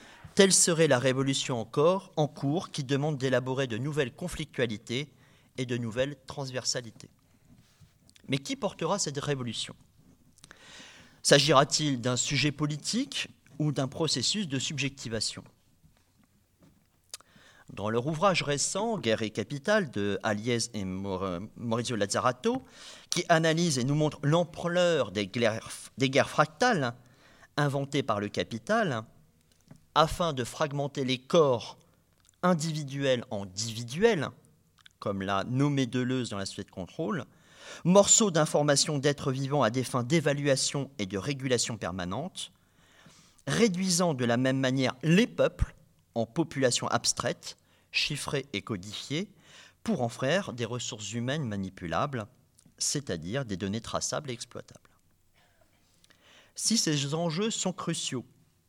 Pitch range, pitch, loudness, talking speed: 115-160 Hz, 135 Hz, -29 LUFS, 120 wpm